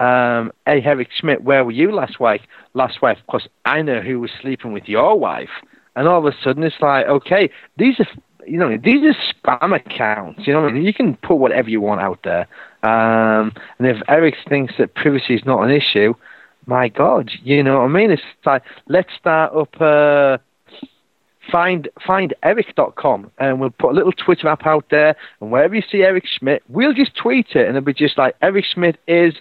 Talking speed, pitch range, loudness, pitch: 210 wpm, 130-175 Hz, -16 LUFS, 145 Hz